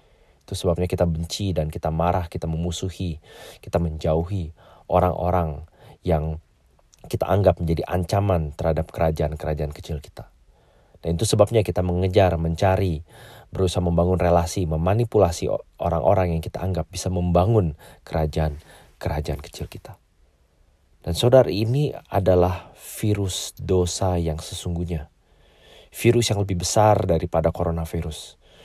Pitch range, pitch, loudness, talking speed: 80-95 Hz, 85 Hz, -23 LUFS, 115 wpm